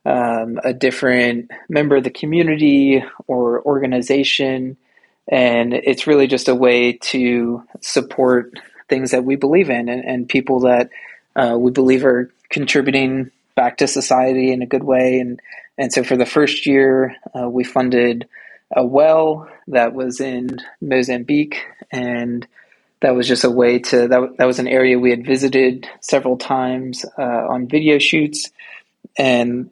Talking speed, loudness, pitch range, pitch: 155 wpm, -16 LUFS, 125-135 Hz, 130 Hz